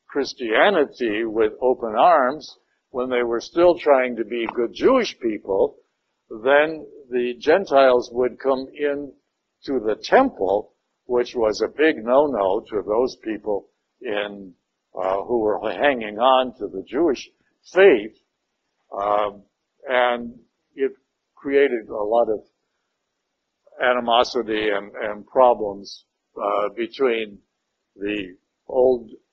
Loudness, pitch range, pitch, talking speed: -21 LUFS, 105-140 Hz, 125 Hz, 115 wpm